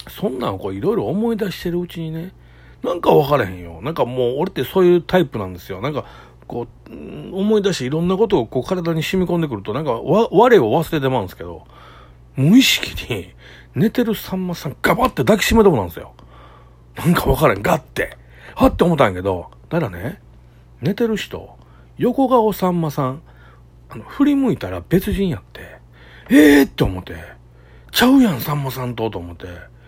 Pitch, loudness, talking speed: 140 Hz, -18 LUFS, 390 characters per minute